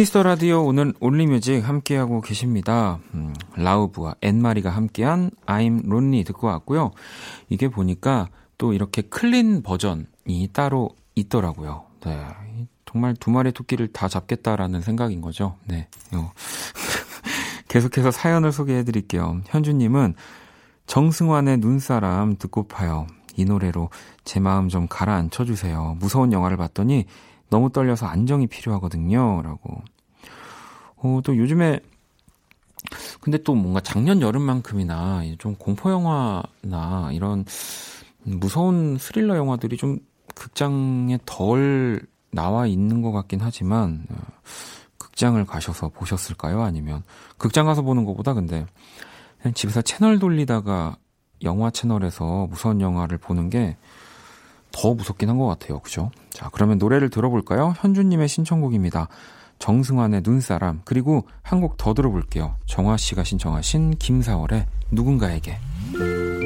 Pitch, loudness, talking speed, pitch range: 110 Hz, -22 LUFS, 290 characters per minute, 95-130 Hz